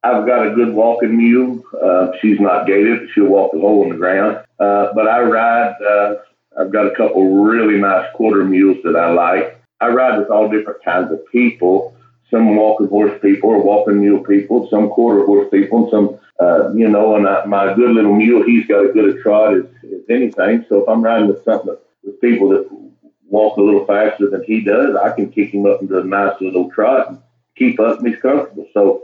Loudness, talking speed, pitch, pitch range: -13 LUFS, 220 wpm, 105 Hz, 100-115 Hz